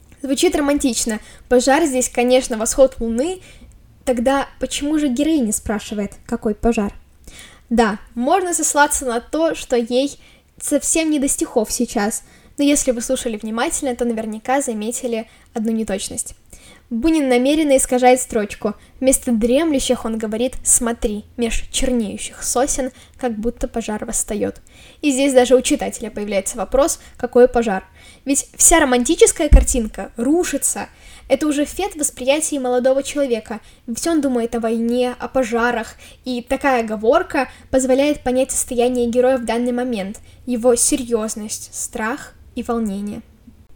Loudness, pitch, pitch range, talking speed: -18 LUFS, 250 Hz, 230-275 Hz, 130 wpm